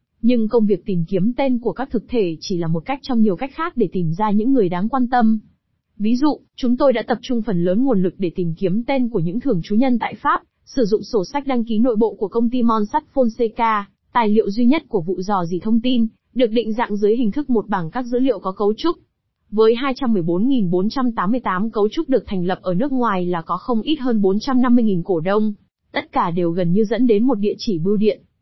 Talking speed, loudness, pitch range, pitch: 245 wpm, -19 LUFS, 200-250 Hz, 225 Hz